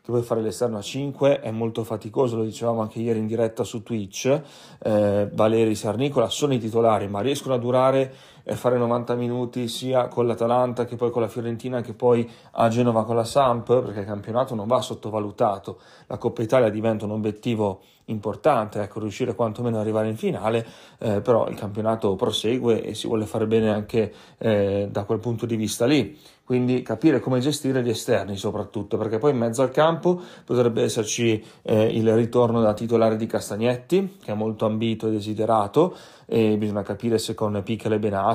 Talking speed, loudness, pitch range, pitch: 190 wpm, -23 LUFS, 110-125 Hz, 115 Hz